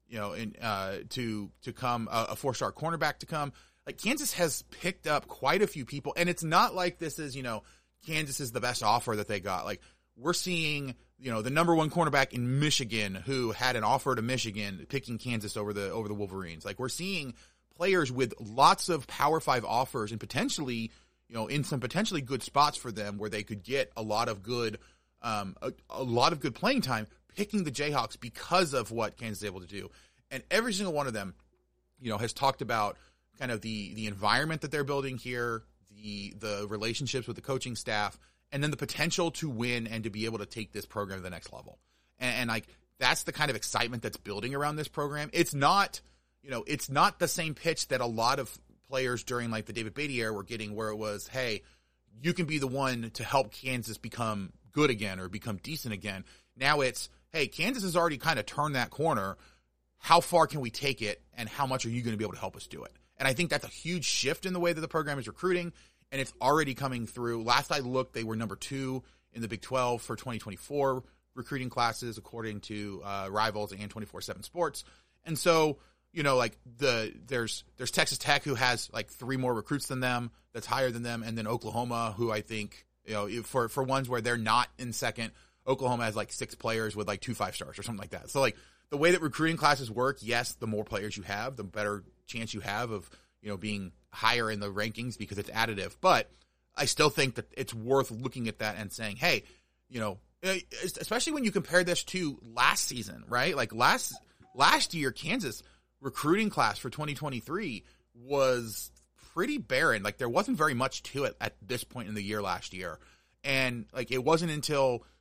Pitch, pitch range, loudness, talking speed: 120 Hz, 105-145 Hz, -31 LUFS, 220 wpm